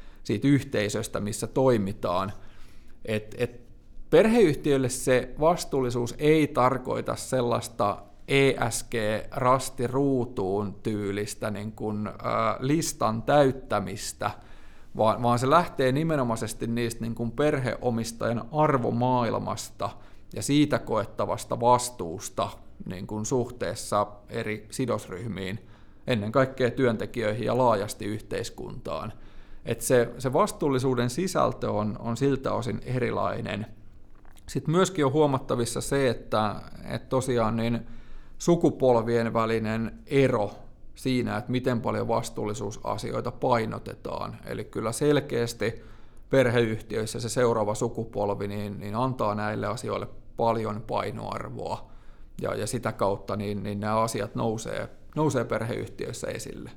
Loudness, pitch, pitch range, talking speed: -27 LUFS, 115 Hz, 105-130 Hz, 100 wpm